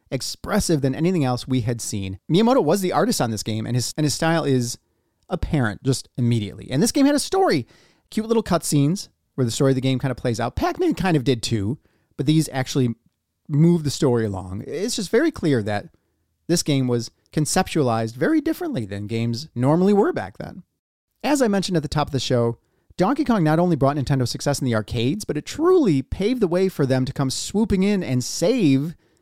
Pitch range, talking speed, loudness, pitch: 120-180 Hz, 215 wpm, -21 LUFS, 140 Hz